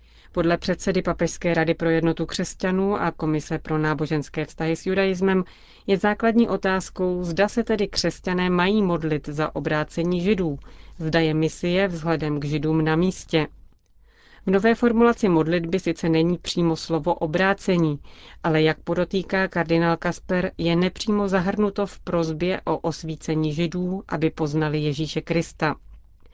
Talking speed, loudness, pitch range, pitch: 135 wpm, -23 LUFS, 160-190 Hz, 170 Hz